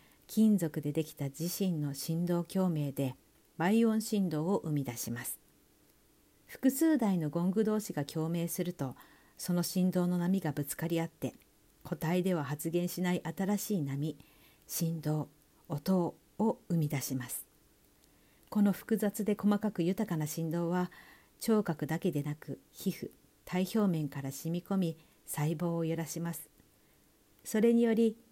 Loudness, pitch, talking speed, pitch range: -33 LUFS, 170 Hz, 260 characters per minute, 155-190 Hz